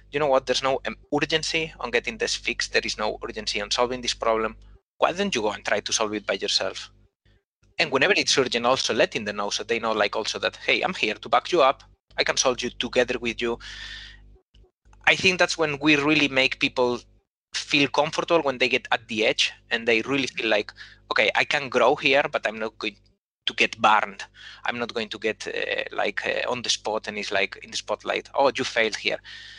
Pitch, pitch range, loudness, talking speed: 130 Hz, 115-160 Hz, -23 LUFS, 225 wpm